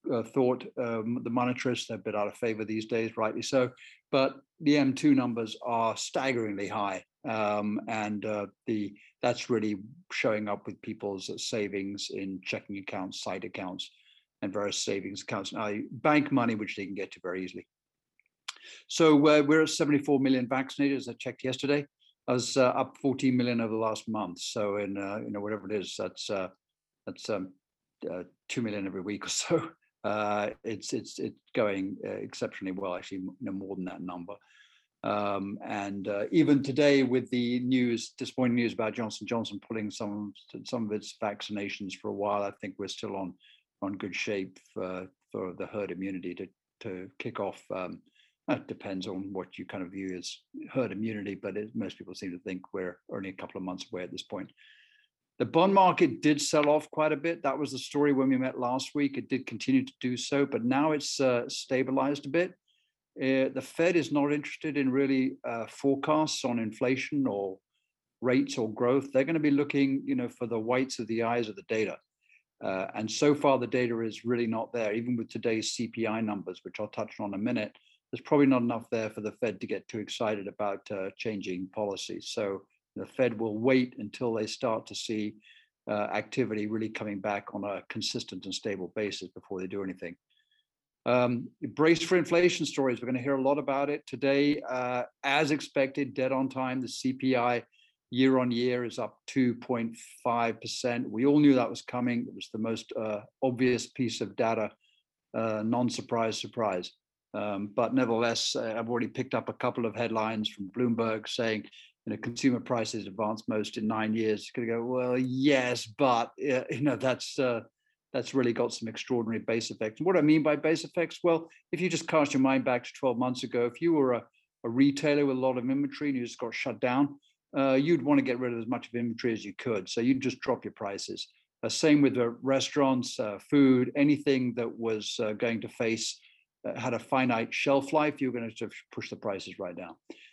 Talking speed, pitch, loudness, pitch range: 205 wpm, 120 Hz, -30 LUFS, 105-135 Hz